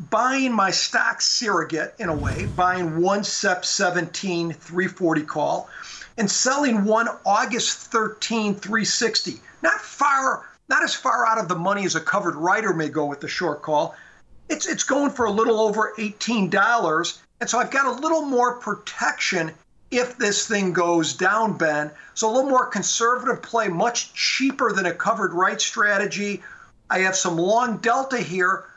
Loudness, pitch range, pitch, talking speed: -22 LUFS, 180-235 Hz, 205 Hz, 165 wpm